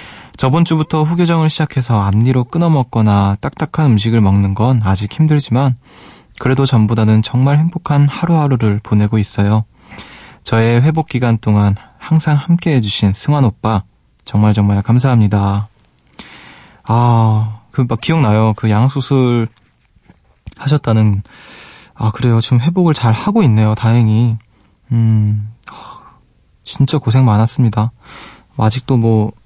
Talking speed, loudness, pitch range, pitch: 275 characters per minute, -13 LUFS, 105-135 Hz, 115 Hz